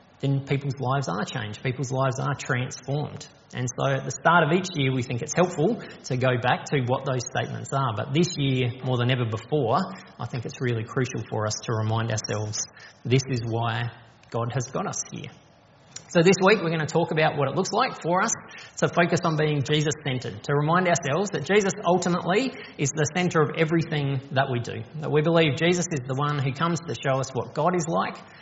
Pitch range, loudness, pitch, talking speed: 125-165 Hz, -25 LUFS, 140 Hz, 220 wpm